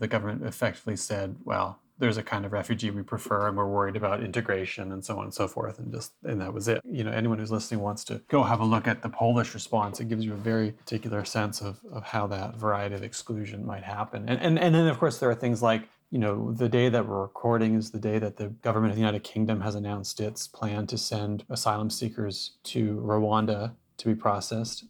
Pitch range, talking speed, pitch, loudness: 105-115 Hz, 240 wpm, 110 Hz, -29 LUFS